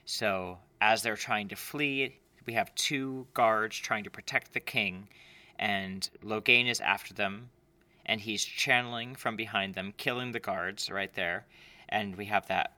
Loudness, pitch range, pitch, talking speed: -31 LUFS, 100-125 Hz, 110 Hz, 165 wpm